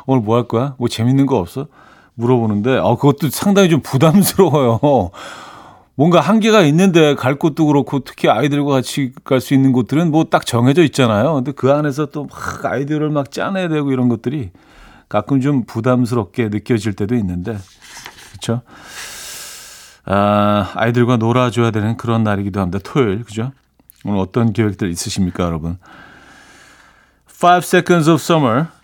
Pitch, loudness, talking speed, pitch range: 125 Hz, -15 LUFS, 345 characters per minute, 115-145 Hz